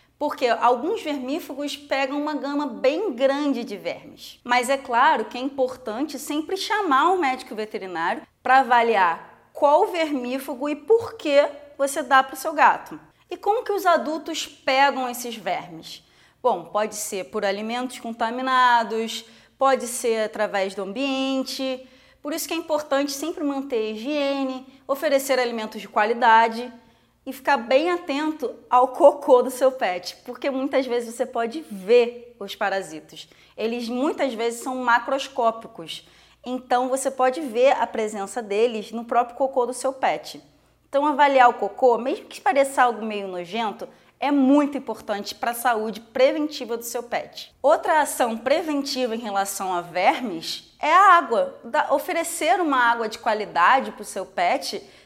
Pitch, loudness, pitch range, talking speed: 260 Hz, -22 LUFS, 230-290 Hz, 155 wpm